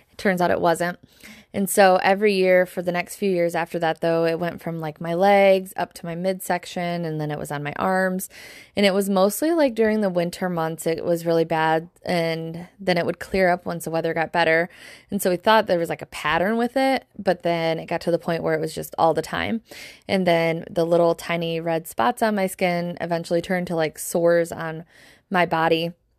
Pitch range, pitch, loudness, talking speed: 165-190 Hz, 175 Hz, -22 LUFS, 230 wpm